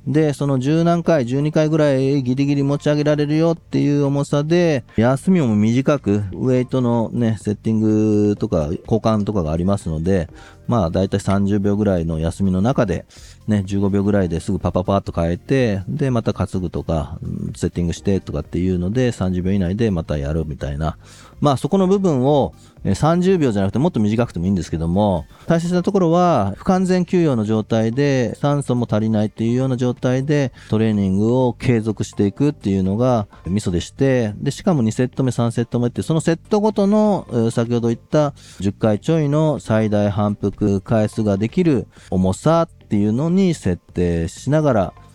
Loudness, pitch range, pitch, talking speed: -19 LUFS, 100-140 Hz, 110 Hz, 365 characters per minute